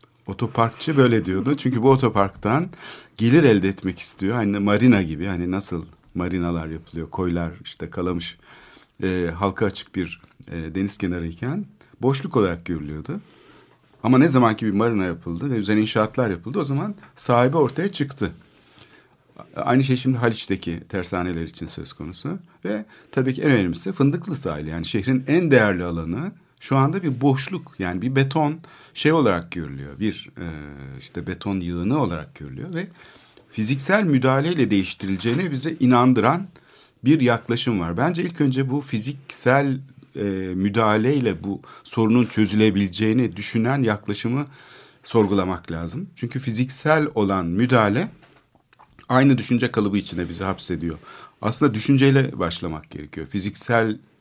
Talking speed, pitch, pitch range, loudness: 130 wpm, 110 Hz, 95-135 Hz, -22 LUFS